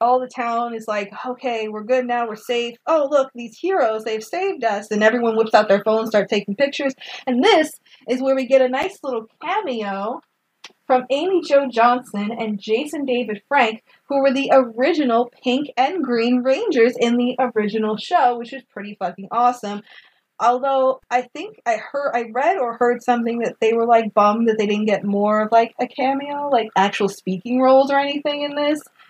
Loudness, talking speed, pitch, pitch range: -19 LUFS, 195 wpm, 245 Hz, 220-270 Hz